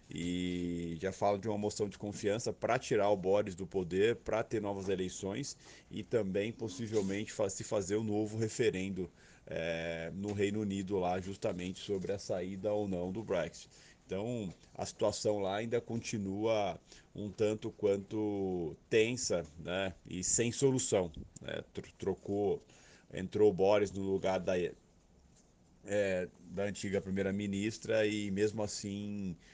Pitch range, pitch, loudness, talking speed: 95-105 Hz, 100 Hz, -36 LUFS, 140 wpm